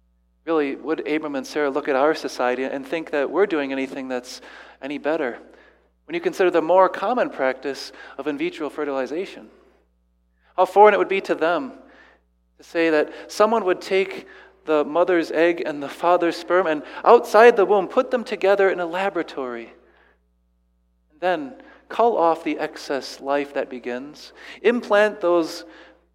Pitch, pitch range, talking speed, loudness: 160 Hz, 135-185 Hz, 160 wpm, -21 LUFS